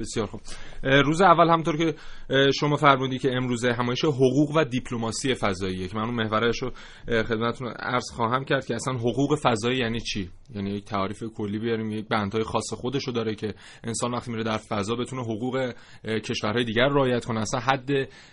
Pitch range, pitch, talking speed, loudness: 110-130 Hz, 120 Hz, 180 wpm, -25 LUFS